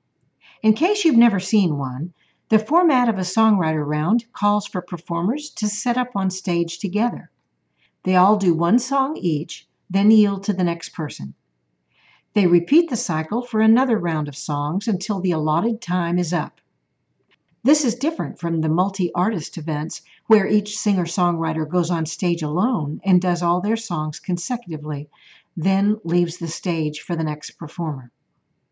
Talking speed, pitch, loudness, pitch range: 165 wpm, 180 Hz, -21 LUFS, 160-215 Hz